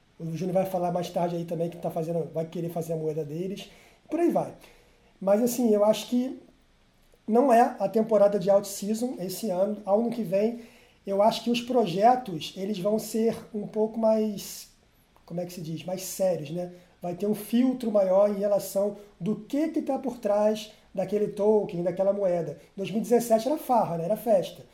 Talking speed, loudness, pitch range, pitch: 195 wpm, -27 LUFS, 180-225 Hz, 205 Hz